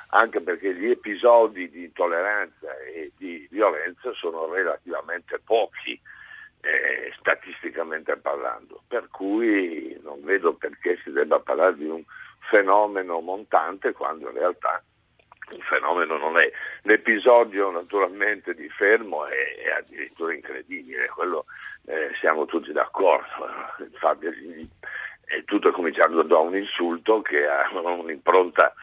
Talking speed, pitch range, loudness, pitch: 120 wpm, 285-440 Hz, -23 LUFS, 395 Hz